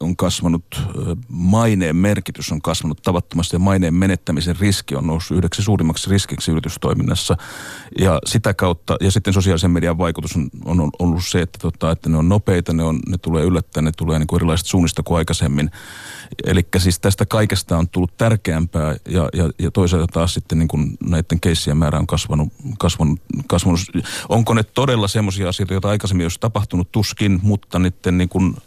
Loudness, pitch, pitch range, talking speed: -18 LUFS, 90 Hz, 80-95 Hz, 170 wpm